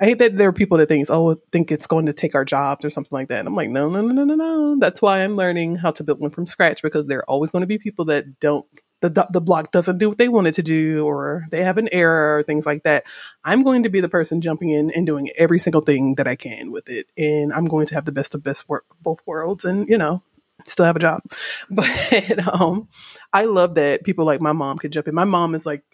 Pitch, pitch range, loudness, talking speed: 160 Hz, 150-185 Hz, -19 LUFS, 280 wpm